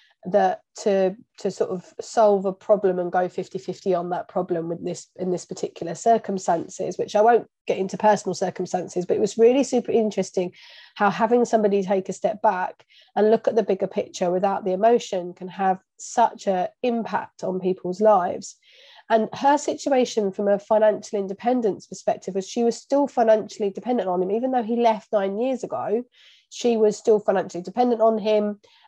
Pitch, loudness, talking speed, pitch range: 210 Hz, -23 LUFS, 180 wpm, 190-230 Hz